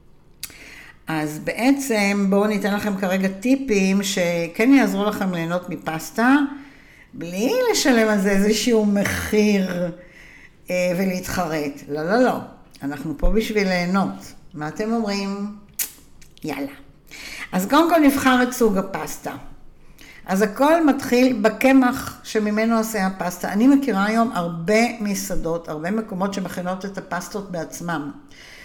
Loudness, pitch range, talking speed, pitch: -21 LUFS, 175-225 Hz, 115 wpm, 200 Hz